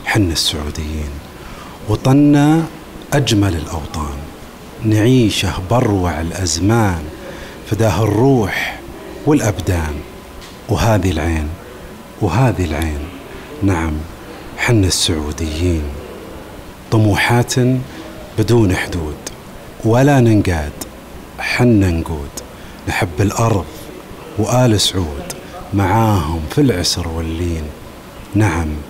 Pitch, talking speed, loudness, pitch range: 100 Hz, 70 wpm, -16 LUFS, 80-115 Hz